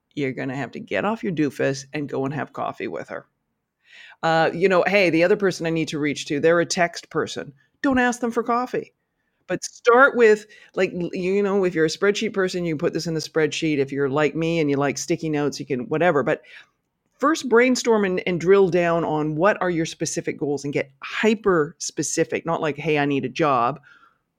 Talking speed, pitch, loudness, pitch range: 220 wpm, 165 Hz, -22 LUFS, 155-195 Hz